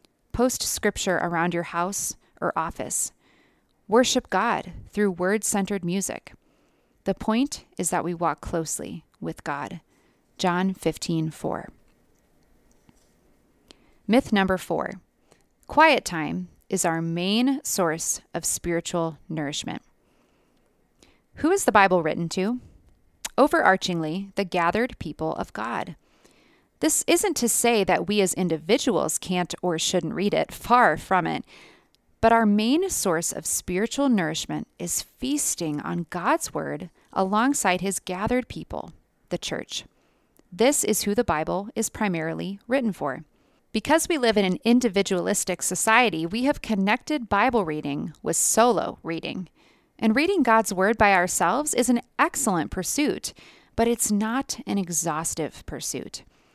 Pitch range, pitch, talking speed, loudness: 175-235 Hz, 200 Hz, 130 wpm, -24 LUFS